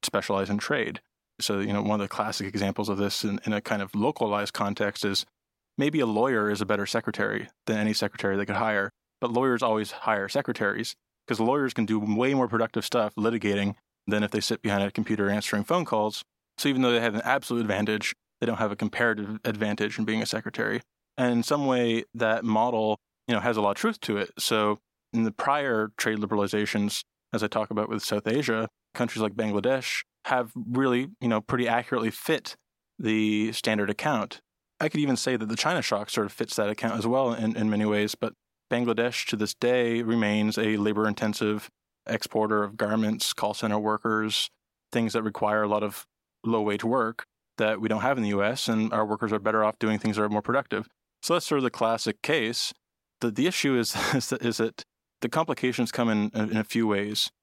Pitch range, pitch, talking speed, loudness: 105-120 Hz, 110 Hz, 210 wpm, -27 LUFS